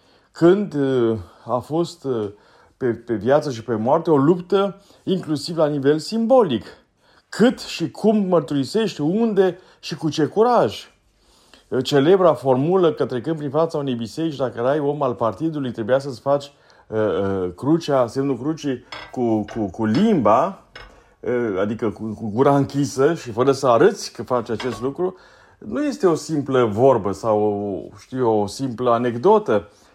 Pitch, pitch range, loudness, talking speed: 140 Hz, 120-165 Hz, -20 LUFS, 145 wpm